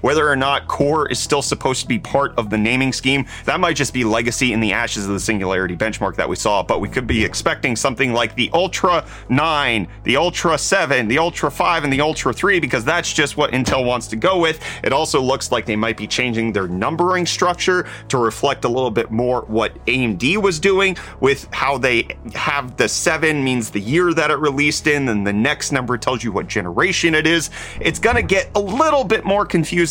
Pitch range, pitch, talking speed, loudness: 115-165 Hz, 135 Hz, 220 wpm, -18 LUFS